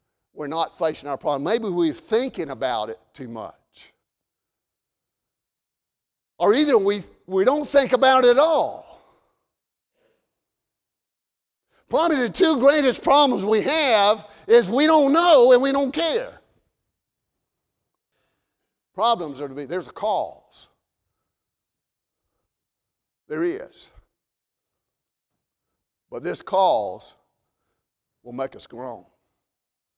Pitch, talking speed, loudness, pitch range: 245 Hz, 105 wpm, -20 LUFS, 175-290 Hz